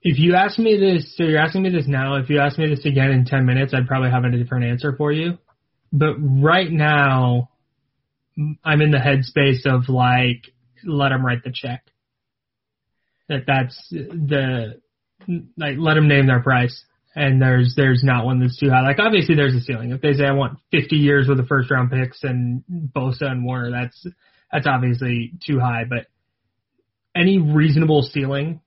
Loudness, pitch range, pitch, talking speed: -18 LUFS, 125-150 Hz, 140 Hz, 185 wpm